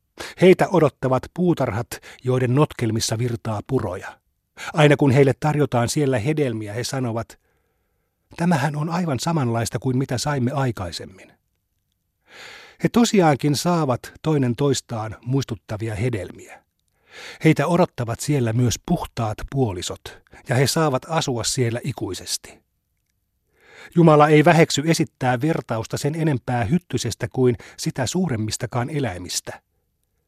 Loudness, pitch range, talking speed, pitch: -21 LUFS, 115-150 Hz, 105 wpm, 130 Hz